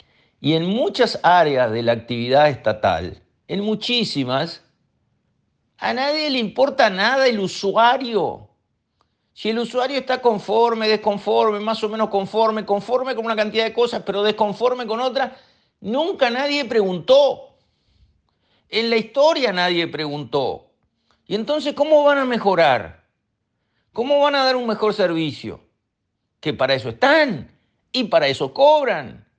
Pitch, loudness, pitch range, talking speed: 220 Hz, -19 LUFS, 185-260 Hz, 135 wpm